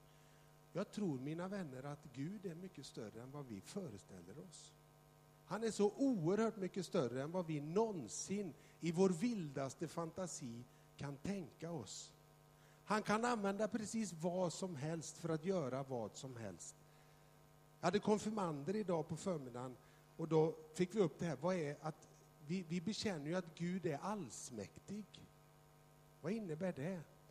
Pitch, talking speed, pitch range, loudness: 165 Hz, 155 wpm, 155-190 Hz, -43 LUFS